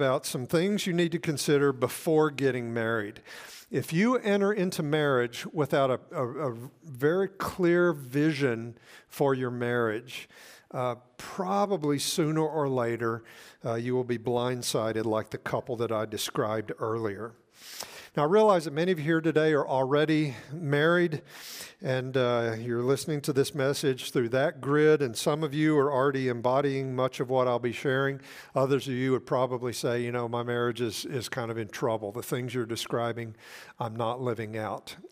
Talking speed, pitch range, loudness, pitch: 170 wpm, 120-155 Hz, -28 LUFS, 130 Hz